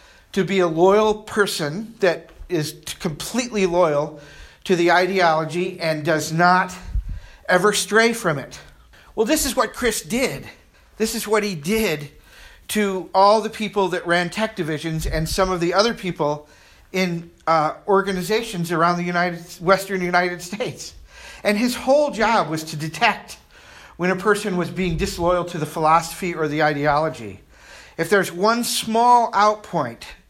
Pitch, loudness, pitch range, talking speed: 180 Hz, -20 LUFS, 160-210 Hz, 150 wpm